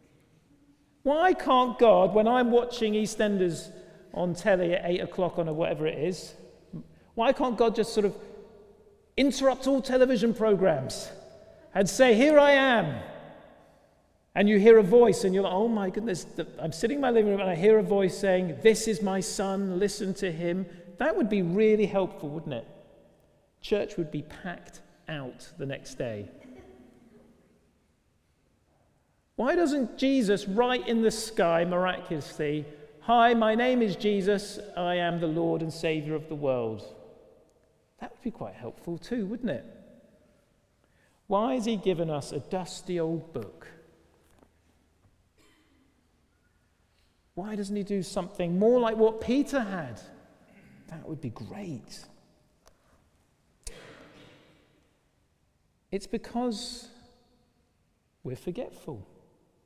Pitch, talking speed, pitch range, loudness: 195 Hz, 135 wpm, 160-225 Hz, -26 LUFS